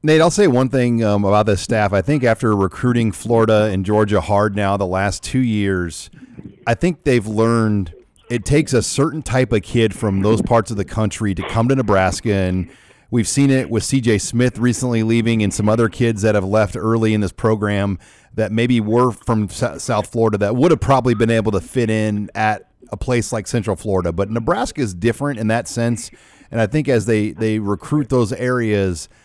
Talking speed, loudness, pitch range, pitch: 205 wpm, -18 LUFS, 105-125 Hz, 110 Hz